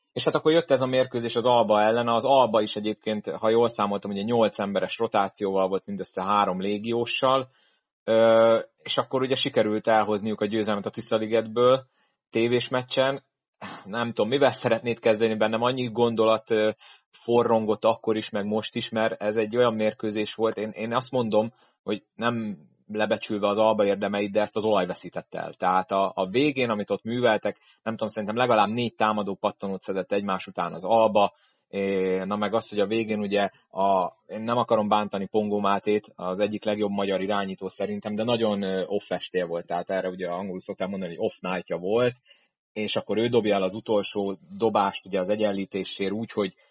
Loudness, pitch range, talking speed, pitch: -25 LUFS, 100-115 Hz, 175 wpm, 110 Hz